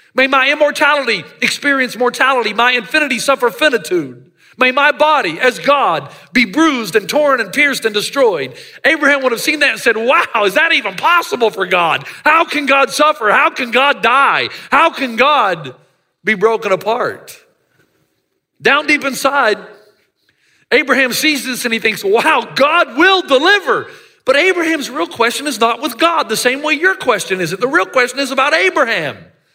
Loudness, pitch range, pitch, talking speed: -13 LUFS, 235-310 Hz, 275 Hz, 170 wpm